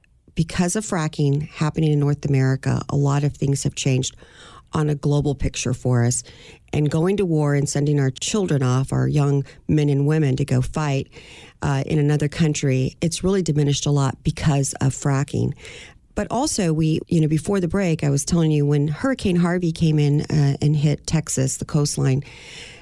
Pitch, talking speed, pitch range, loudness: 145 Hz, 185 wpm, 135-155 Hz, -21 LUFS